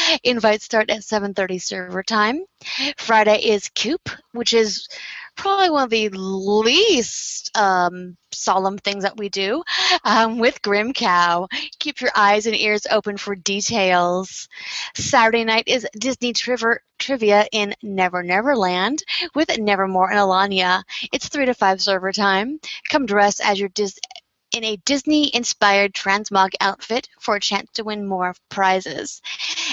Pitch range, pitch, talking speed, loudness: 195-245 Hz, 210 Hz, 145 wpm, -19 LUFS